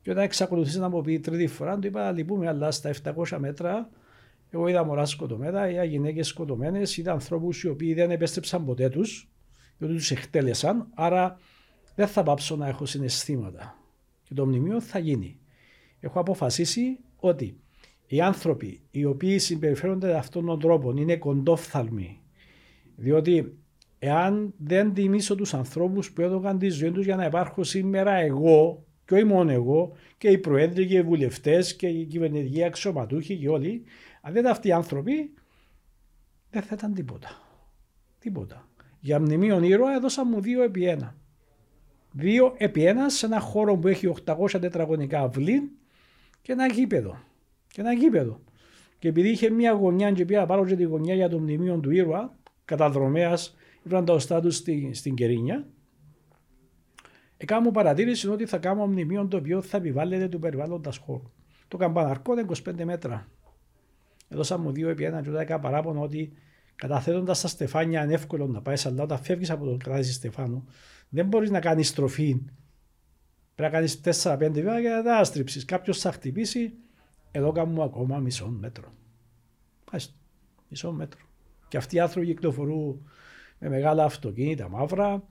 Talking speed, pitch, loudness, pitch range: 160 wpm, 165 Hz, -26 LUFS, 145-190 Hz